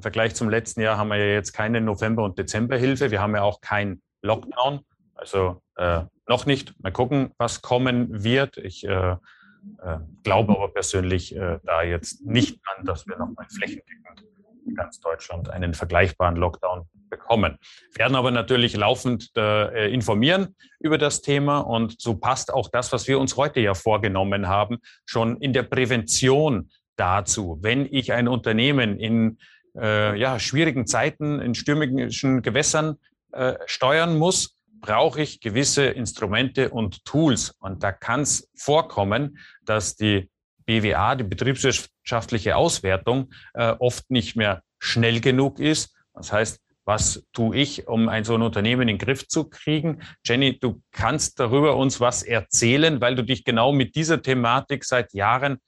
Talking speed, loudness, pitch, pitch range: 155 wpm, -22 LUFS, 120 Hz, 105-135 Hz